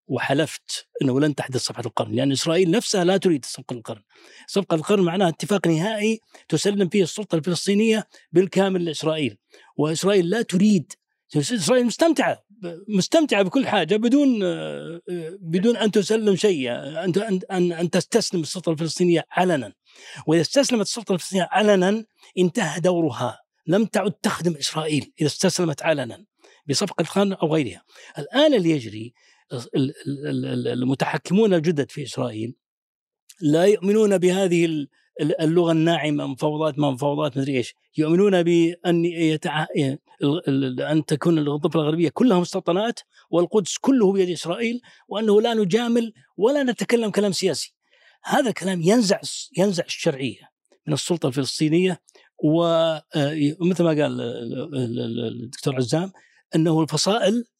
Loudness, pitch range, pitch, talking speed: -22 LUFS, 150-200 Hz, 170 Hz, 120 wpm